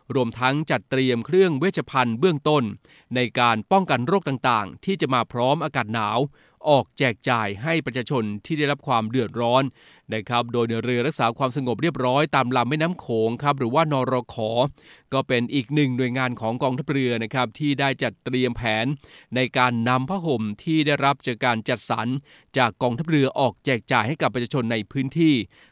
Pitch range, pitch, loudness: 120-145 Hz, 130 Hz, -23 LUFS